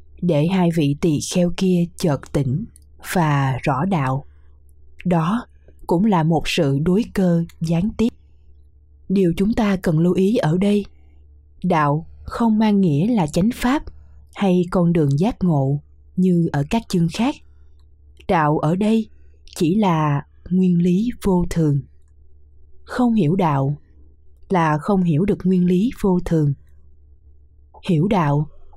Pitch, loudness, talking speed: 165 Hz, -19 LUFS, 140 wpm